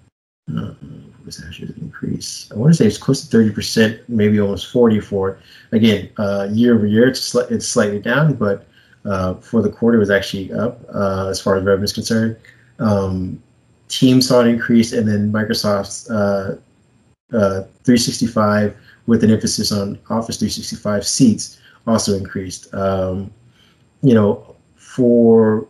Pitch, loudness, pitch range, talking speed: 105 Hz, -17 LUFS, 100-115 Hz, 155 wpm